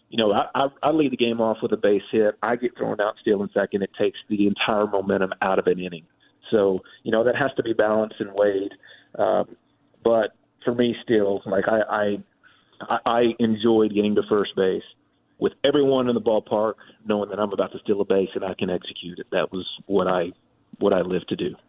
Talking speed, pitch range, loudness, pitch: 220 wpm, 100-115 Hz, -23 LUFS, 105 Hz